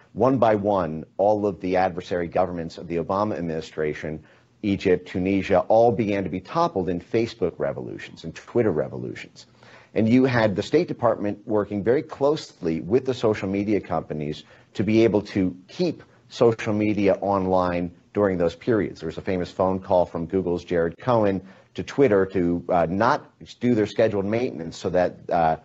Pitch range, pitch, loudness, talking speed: 85-110 Hz, 95 Hz, -23 LUFS, 170 wpm